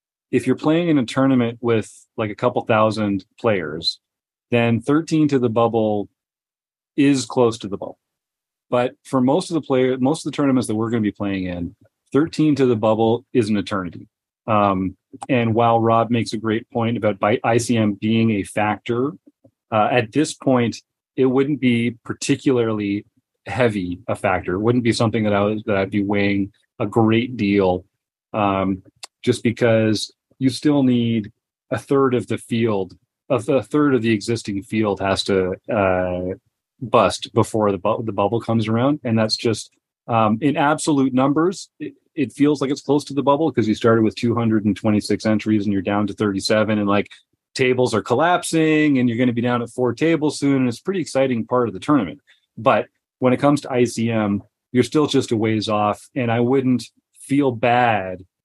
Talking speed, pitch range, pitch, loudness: 190 wpm, 105-130 Hz, 115 Hz, -20 LUFS